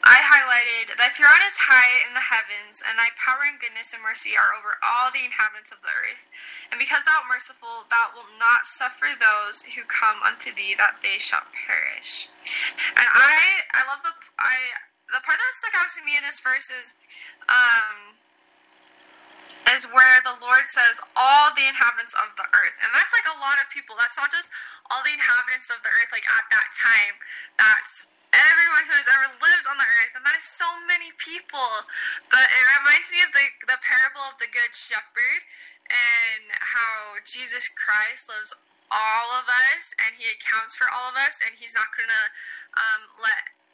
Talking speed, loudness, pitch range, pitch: 190 wpm, -19 LUFS, 235-335 Hz, 260 Hz